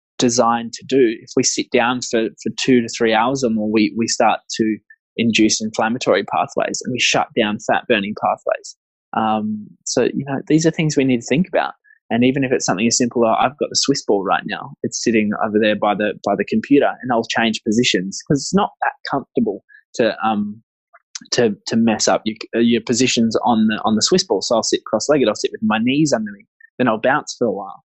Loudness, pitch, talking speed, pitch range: -18 LUFS, 115 Hz, 230 wpm, 110-155 Hz